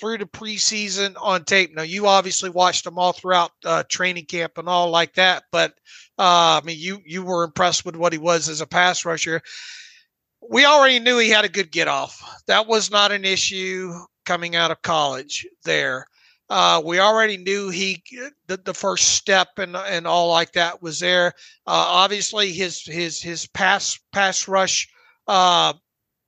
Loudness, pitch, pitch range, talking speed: -19 LUFS, 185 Hz, 175-200 Hz, 180 wpm